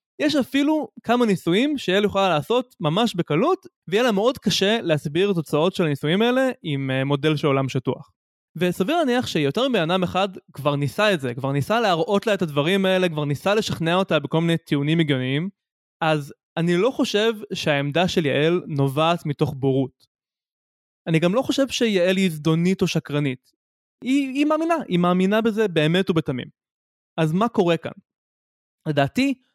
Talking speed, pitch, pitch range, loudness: 165 wpm, 175 Hz, 150-215 Hz, -21 LUFS